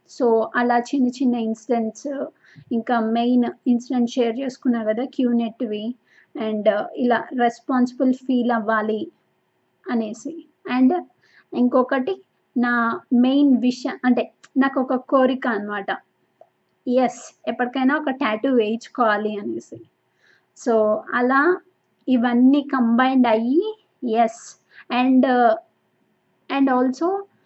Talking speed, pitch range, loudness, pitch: 95 wpm, 230-270 Hz, -21 LUFS, 250 Hz